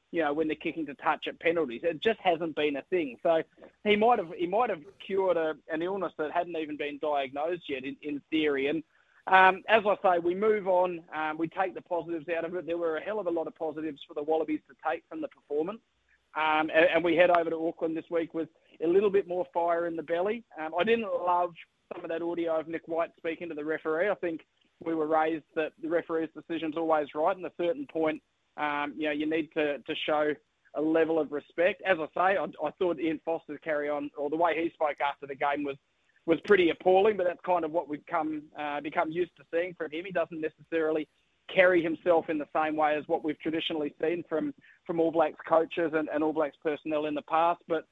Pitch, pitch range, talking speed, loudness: 160 Hz, 155-175 Hz, 245 wpm, -29 LUFS